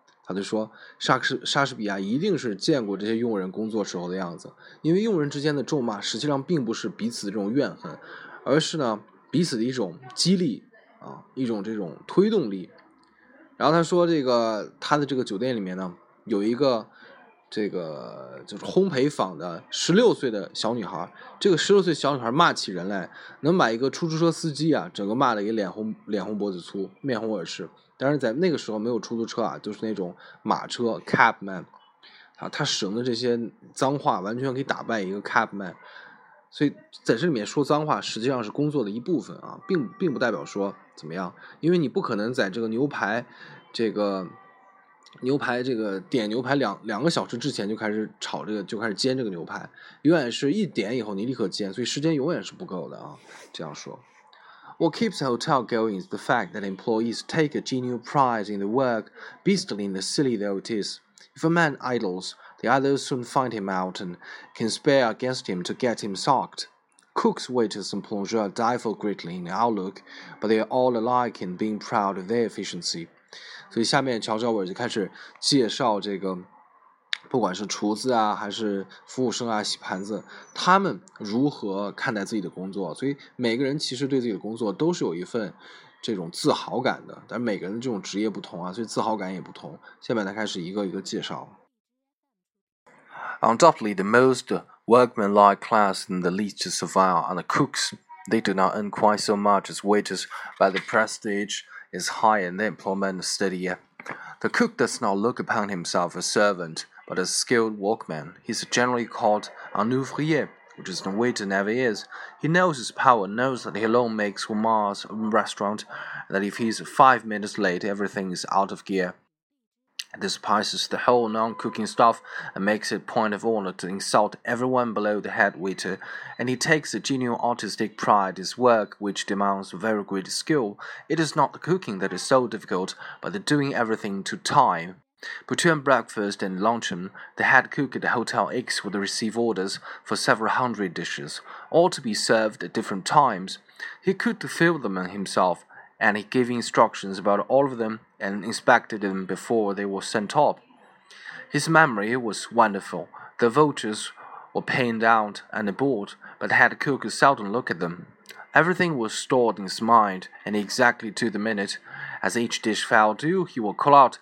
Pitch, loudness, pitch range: 115 Hz, -25 LUFS, 100-135 Hz